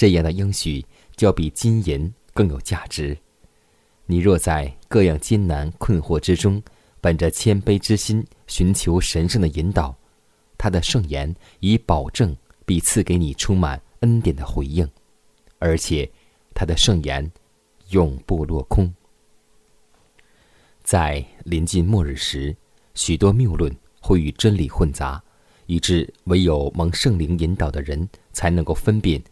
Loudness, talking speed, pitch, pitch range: -21 LUFS, 200 characters per minute, 85 Hz, 75-100 Hz